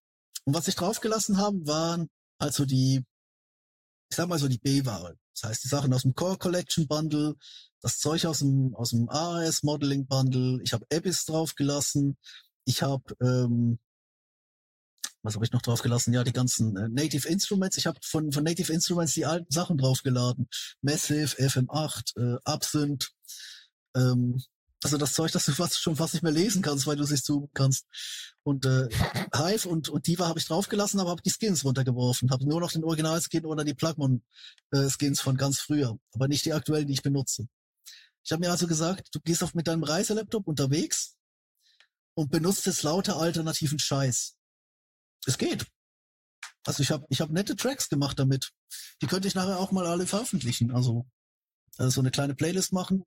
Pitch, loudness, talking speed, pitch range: 150 Hz, -28 LUFS, 180 wpm, 130-165 Hz